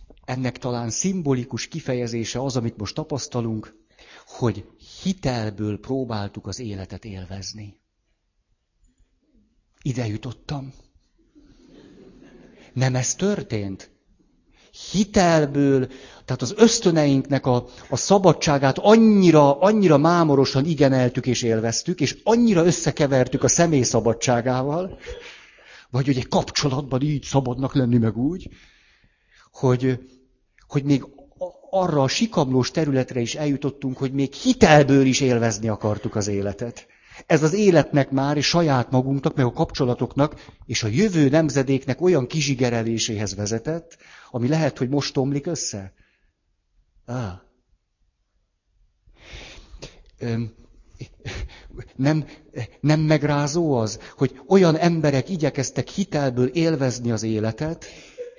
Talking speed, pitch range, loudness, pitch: 105 wpm, 115-155 Hz, -21 LUFS, 135 Hz